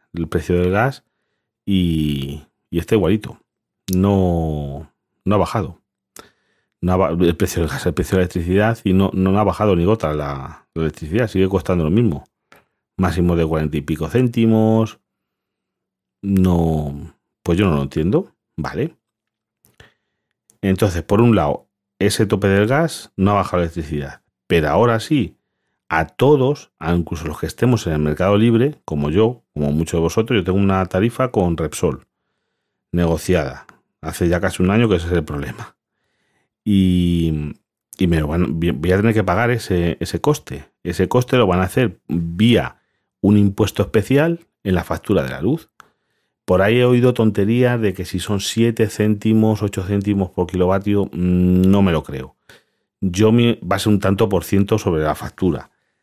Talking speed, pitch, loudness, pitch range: 170 wpm, 95 Hz, -18 LUFS, 85-110 Hz